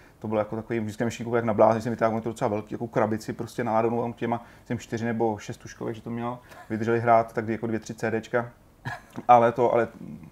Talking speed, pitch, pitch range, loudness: 220 wpm, 115 Hz, 110-120 Hz, -26 LUFS